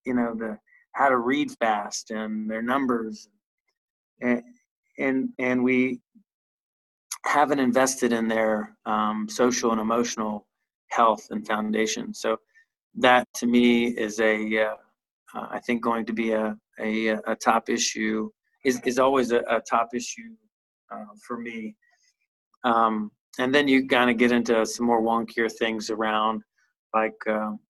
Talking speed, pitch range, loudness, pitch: 145 wpm, 110-130 Hz, -24 LUFS, 120 Hz